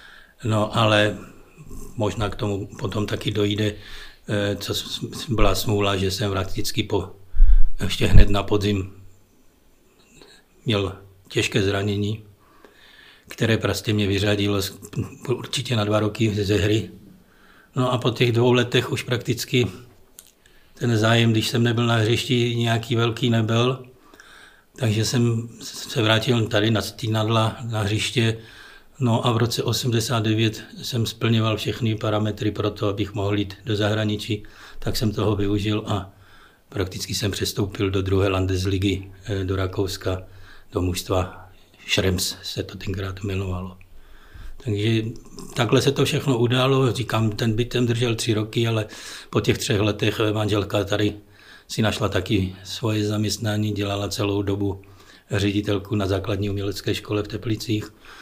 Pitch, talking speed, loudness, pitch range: 105 Hz, 135 wpm, -23 LUFS, 100-115 Hz